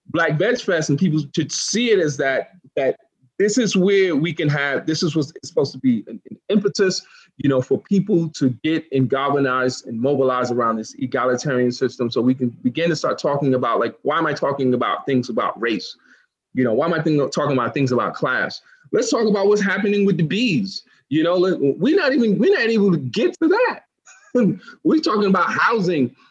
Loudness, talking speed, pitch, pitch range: -20 LUFS, 210 wpm, 160 Hz, 130-200 Hz